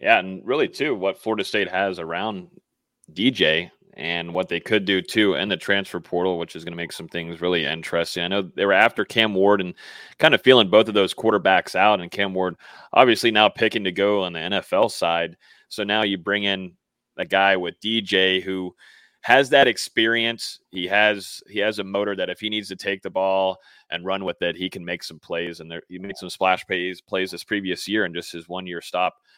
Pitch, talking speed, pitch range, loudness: 95 Hz, 225 wpm, 90-100 Hz, -21 LUFS